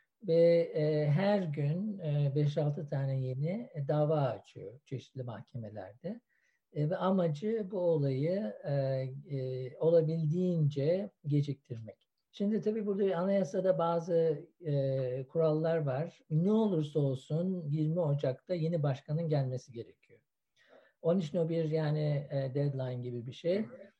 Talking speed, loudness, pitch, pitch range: 115 wpm, -32 LUFS, 155 Hz, 140-175 Hz